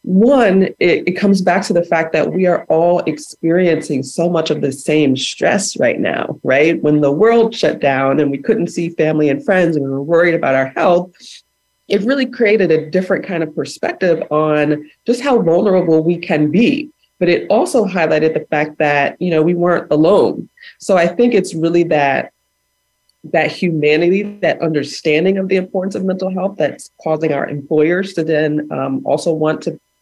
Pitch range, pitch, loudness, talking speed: 150-190 Hz, 165 Hz, -15 LUFS, 190 wpm